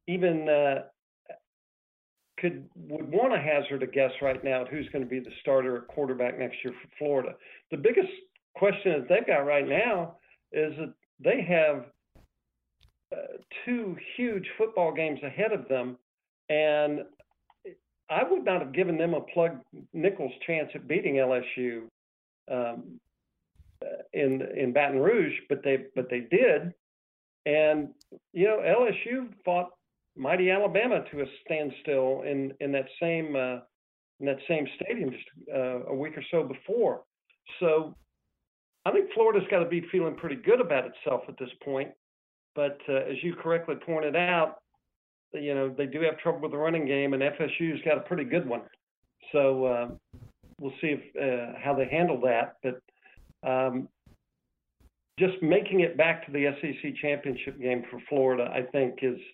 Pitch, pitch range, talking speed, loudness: 145 Hz, 130-170 Hz, 160 wpm, -28 LUFS